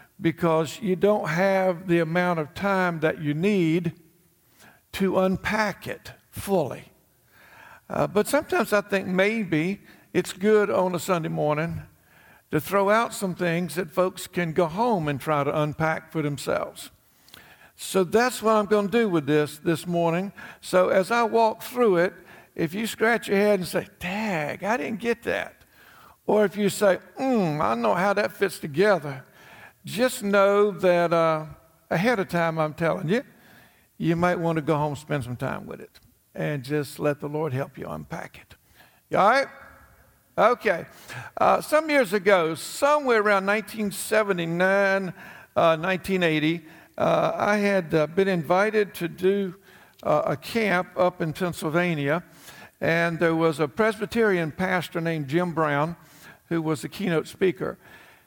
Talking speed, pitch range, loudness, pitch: 160 wpm, 160-205 Hz, -24 LUFS, 180 Hz